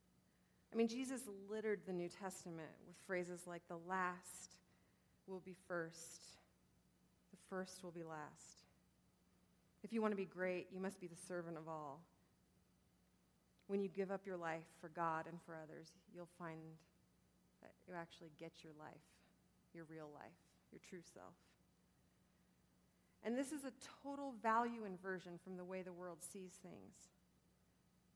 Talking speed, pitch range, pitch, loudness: 155 wpm, 165-195 Hz, 180 Hz, -48 LUFS